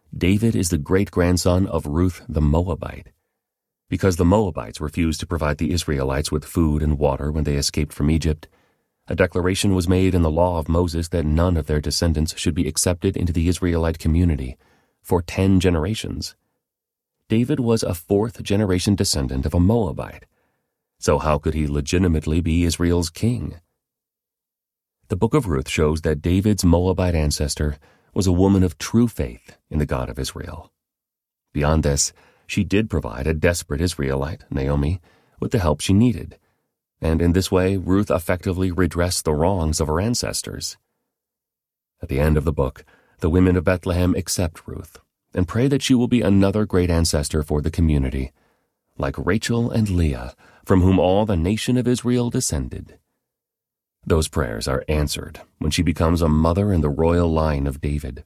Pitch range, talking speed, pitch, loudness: 75-95 Hz, 170 wpm, 85 Hz, -21 LUFS